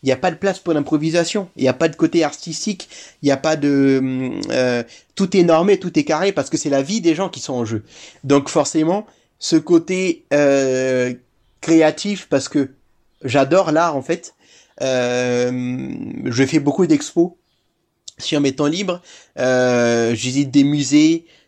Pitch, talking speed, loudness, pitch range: 150 Hz, 175 wpm, -18 LUFS, 130-170 Hz